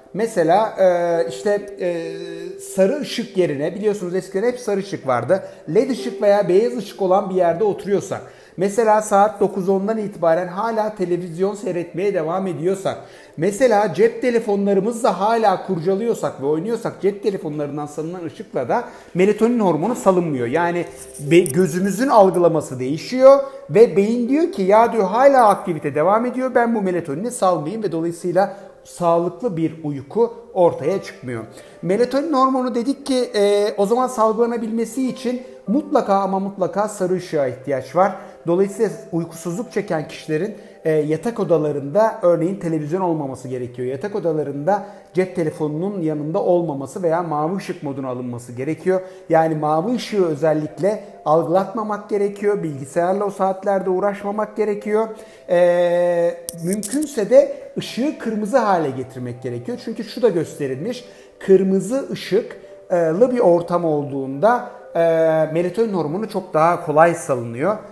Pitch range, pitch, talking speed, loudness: 165-215 Hz, 190 Hz, 125 wpm, -19 LUFS